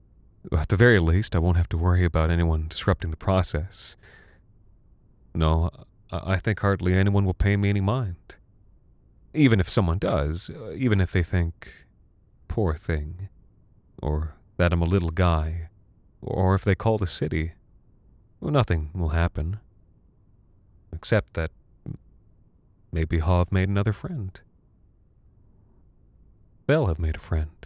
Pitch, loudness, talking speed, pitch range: 95 Hz, -25 LUFS, 135 wpm, 85-100 Hz